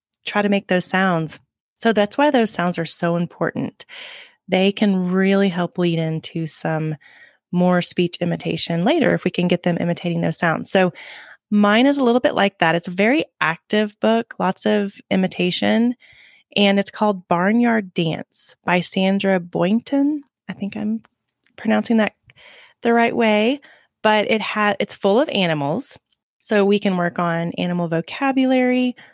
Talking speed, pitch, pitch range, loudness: 160 wpm, 200 Hz, 175-230 Hz, -19 LUFS